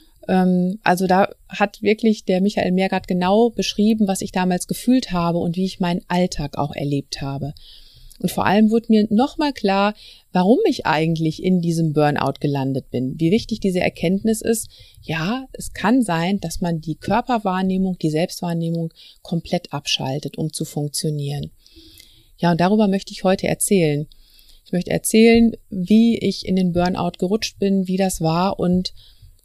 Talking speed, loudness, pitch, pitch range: 160 wpm, -20 LUFS, 185 Hz, 160-205 Hz